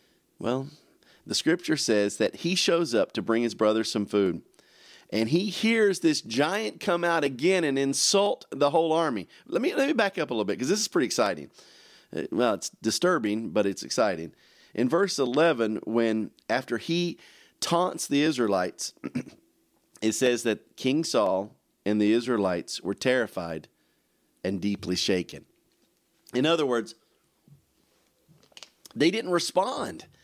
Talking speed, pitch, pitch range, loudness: 150 wpm, 135 Hz, 110-170 Hz, -26 LUFS